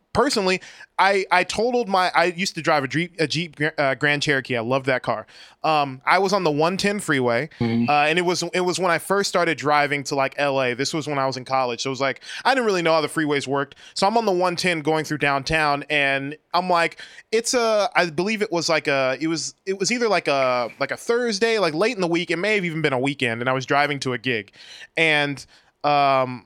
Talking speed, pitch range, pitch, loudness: 250 wpm, 140-180 Hz, 155 Hz, -21 LUFS